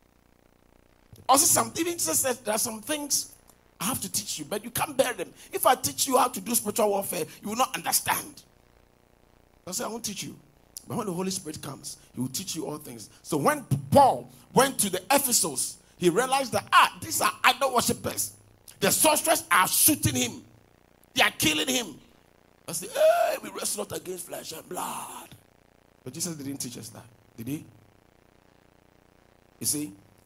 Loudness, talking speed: -25 LUFS, 180 wpm